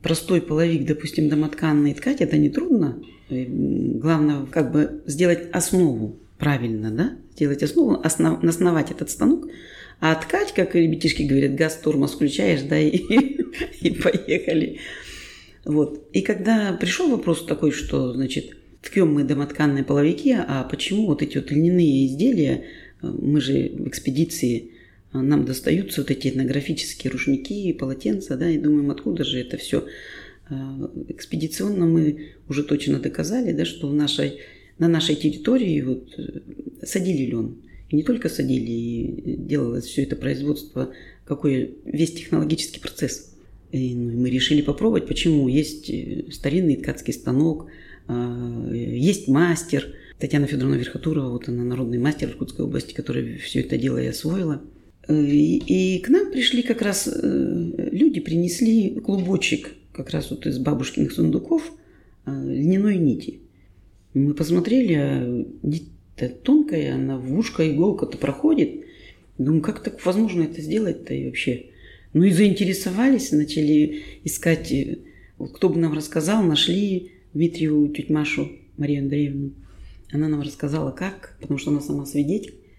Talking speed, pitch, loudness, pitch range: 135 wpm, 150 Hz, -22 LUFS, 140-175 Hz